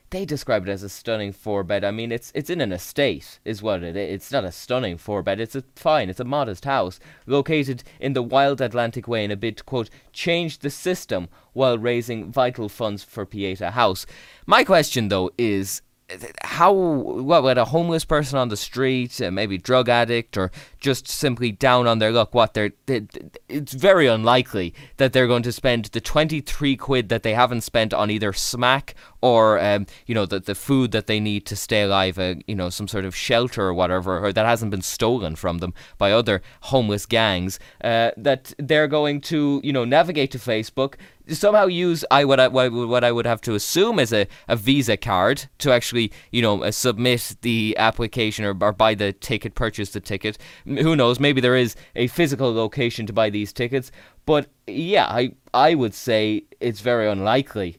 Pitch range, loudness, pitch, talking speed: 105-135 Hz, -21 LUFS, 115 Hz, 200 wpm